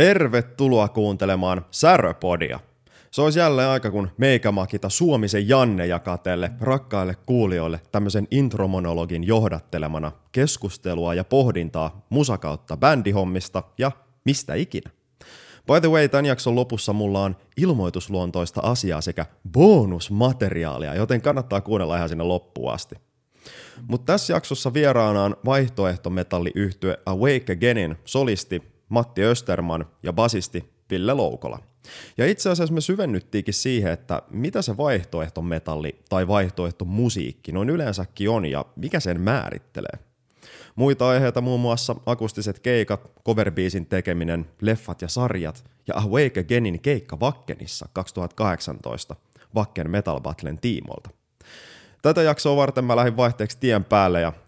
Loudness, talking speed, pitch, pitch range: -22 LUFS, 120 wpm, 105 Hz, 90-125 Hz